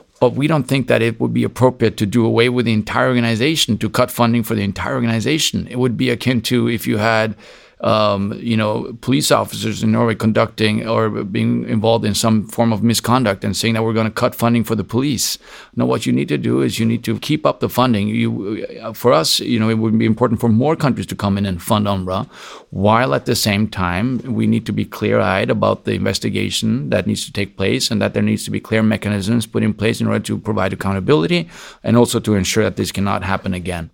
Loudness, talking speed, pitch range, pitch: -17 LUFS, 235 wpm, 105-120 Hz, 110 Hz